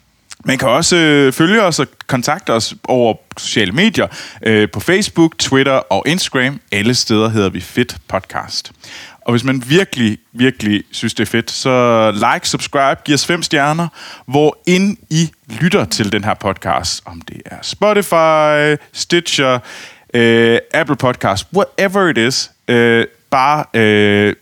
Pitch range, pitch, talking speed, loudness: 115-160 Hz, 130 Hz, 140 wpm, -14 LUFS